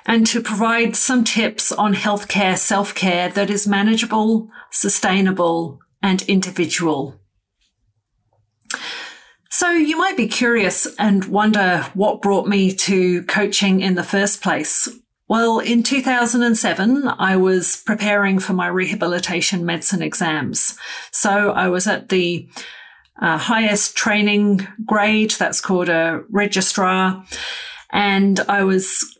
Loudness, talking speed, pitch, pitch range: -17 LUFS, 120 wpm, 200 Hz, 185-220 Hz